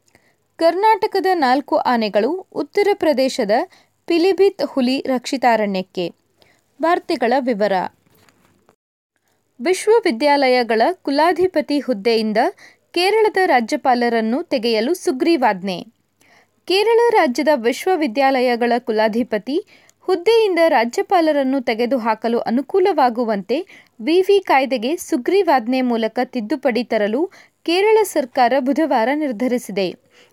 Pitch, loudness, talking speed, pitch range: 285 Hz, -18 LUFS, 70 wpm, 245-360 Hz